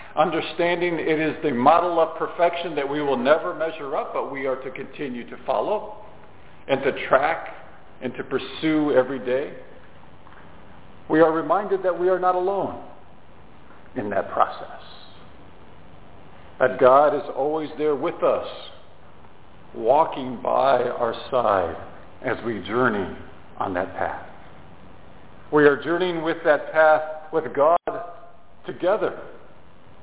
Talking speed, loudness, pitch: 130 wpm, -22 LUFS, 155 Hz